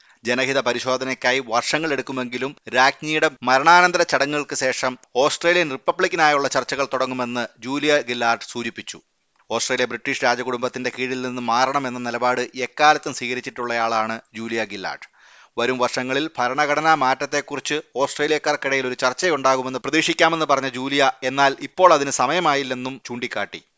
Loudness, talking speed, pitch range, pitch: -20 LUFS, 105 wpm, 125-145 Hz, 130 Hz